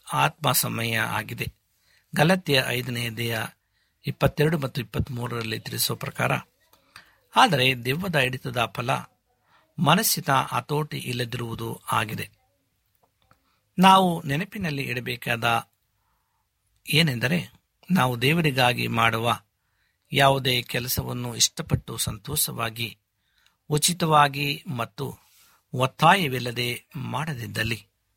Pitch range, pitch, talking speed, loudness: 115-145 Hz, 125 Hz, 75 wpm, -24 LUFS